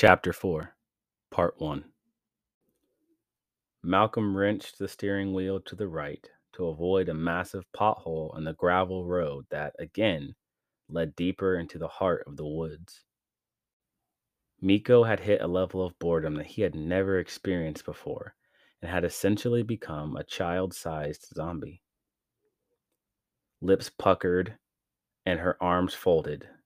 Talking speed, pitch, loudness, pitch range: 130 wpm, 95 Hz, -29 LUFS, 85-100 Hz